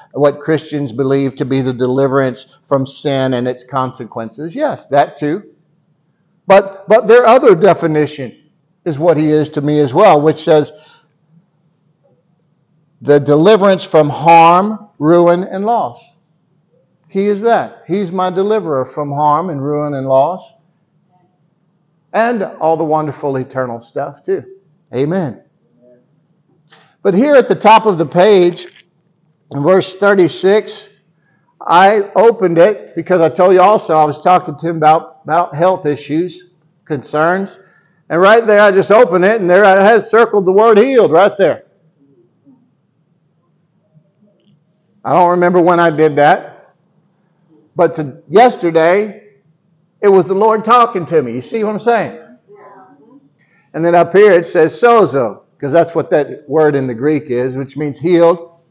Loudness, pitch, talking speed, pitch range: -11 LUFS, 170 Hz, 145 wpm, 150-190 Hz